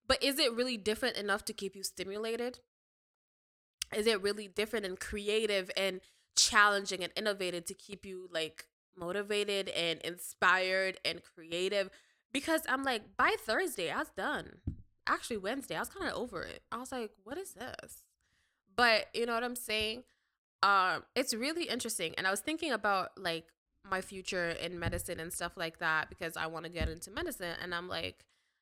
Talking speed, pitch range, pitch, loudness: 180 wpm, 180-230 Hz, 200 Hz, -34 LUFS